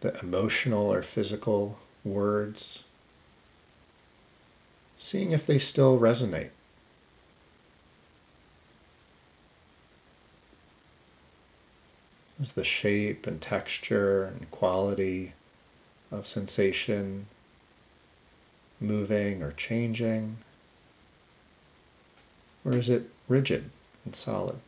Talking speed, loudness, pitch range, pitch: 70 wpm, -29 LUFS, 85-115 Hz, 100 Hz